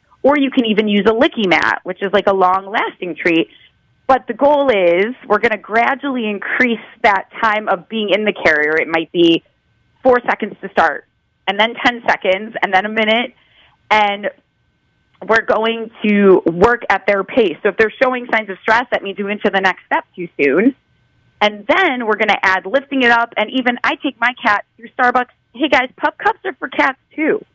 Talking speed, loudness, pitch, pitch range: 205 wpm, -15 LUFS, 220 Hz, 200-255 Hz